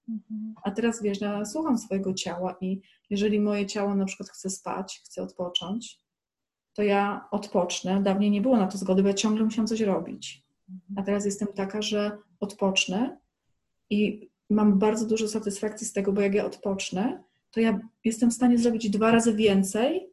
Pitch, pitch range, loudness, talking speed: 205 Hz, 195-220 Hz, -26 LUFS, 175 wpm